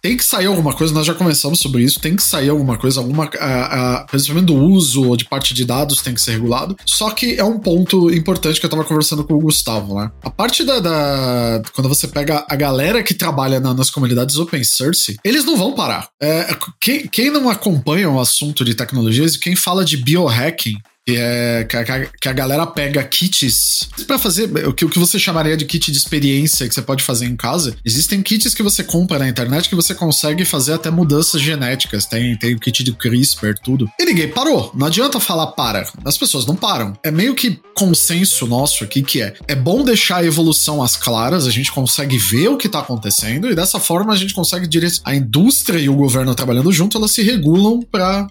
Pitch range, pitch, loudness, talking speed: 130-180 Hz, 150 Hz, -15 LUFS, 215 wpm